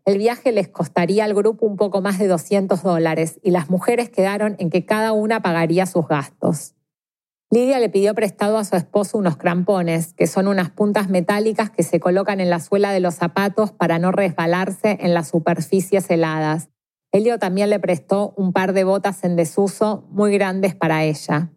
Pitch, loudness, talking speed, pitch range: 195 Hz, -19 LUFS, 185 wpm, 175-205 Hz